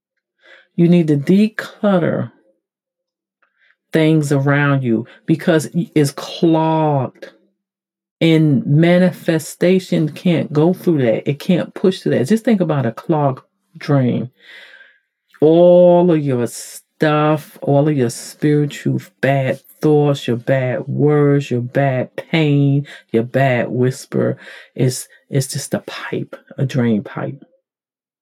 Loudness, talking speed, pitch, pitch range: -16 LUFS, 115 wpm, 150 Hz, 135-175 Hz